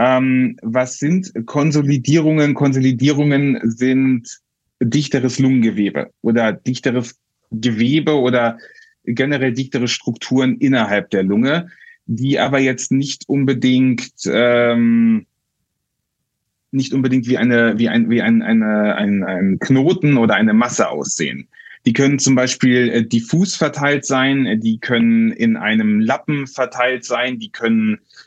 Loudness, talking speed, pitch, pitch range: -16 LUFS, 115 wpm, 130 Hz, 120-150 Hz